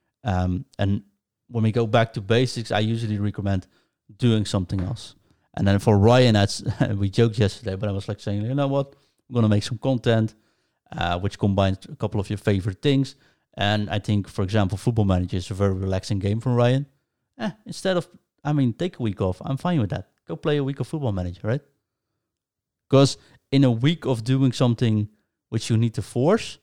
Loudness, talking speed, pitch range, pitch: -23 LUFS, 205 wpm, 100-130 Hz, 110 Hz